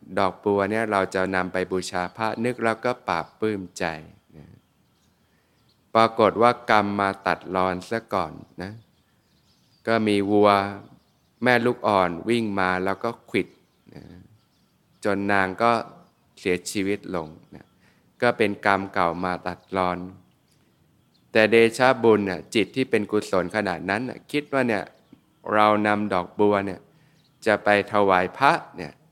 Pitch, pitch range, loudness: 100 Hz, 95-115 Hz, -23 LUFS